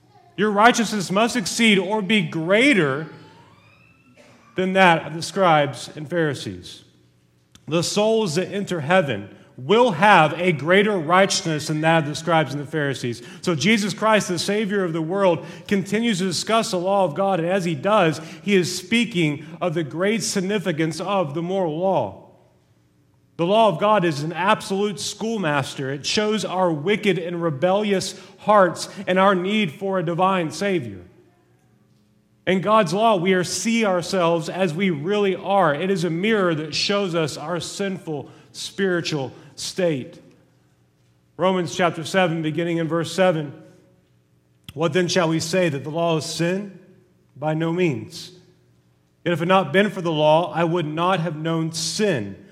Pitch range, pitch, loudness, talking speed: 155-195 Hz, 175 Hz, -21 LUFS, 160 wpm